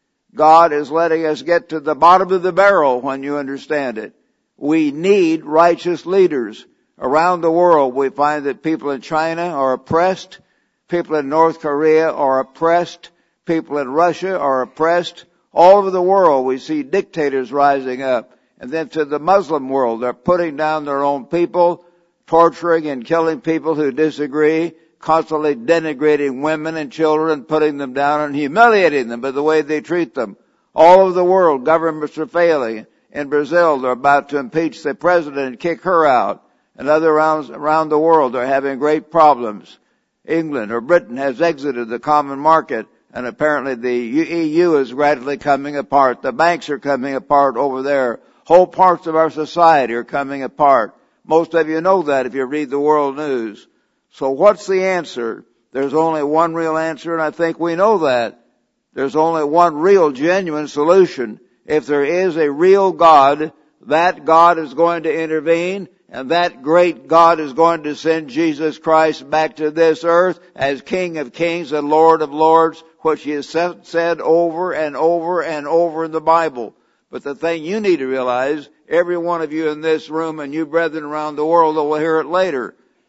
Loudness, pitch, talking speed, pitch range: -16 LUFS, 160 Hz, 180 wpm, 145-170 Hz